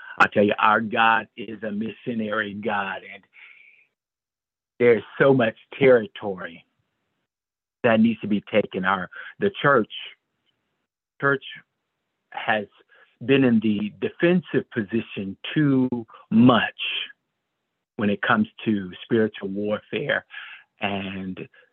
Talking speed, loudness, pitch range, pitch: 105 wpm, -23 LUFS, 100-125 Hz, 110 Hz